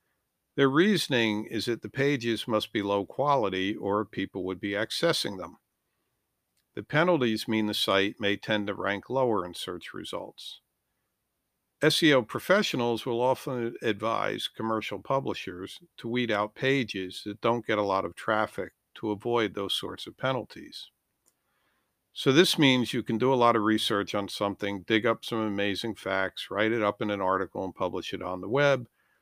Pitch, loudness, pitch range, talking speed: 110 Hz, -28 LUFS, 100-120 Hz, 170 wpm